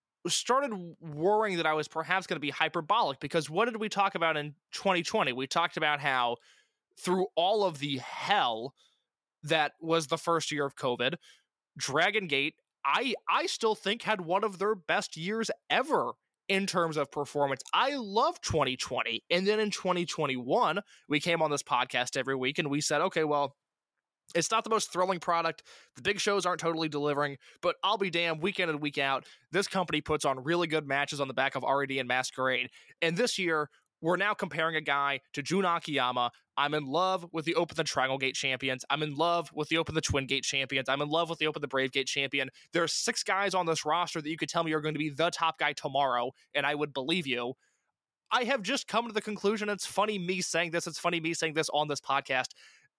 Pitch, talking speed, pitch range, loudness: 165 Hz, 215 wpm, 145-185 Hz, -30 LUFS